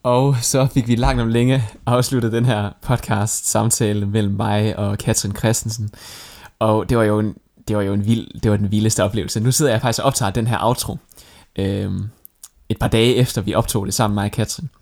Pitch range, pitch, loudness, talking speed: 105-120 Hz, 110 Hz, -19 LUFS, 215 wpm